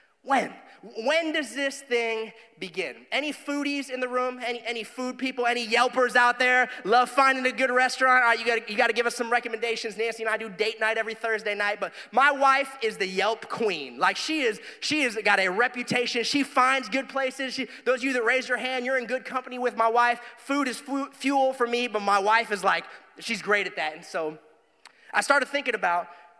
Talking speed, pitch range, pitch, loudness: 225 wpm, 225-260 Hz, 245 Hz, -25 LUFS